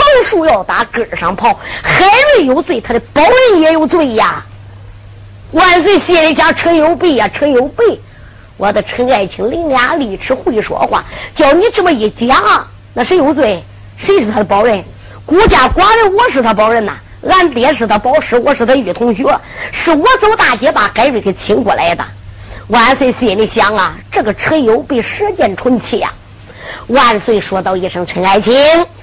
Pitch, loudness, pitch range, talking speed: 255 Hz, -10 LUFS, 205-335 Hz, 250 characters per minute